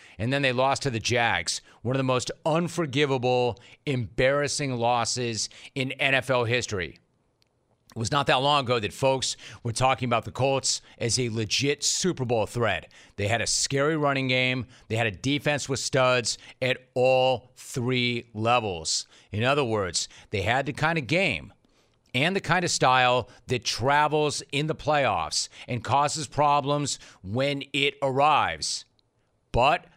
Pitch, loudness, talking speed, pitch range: 130 Hz, -25 LUFS, 155 wpm, 120-145 Hz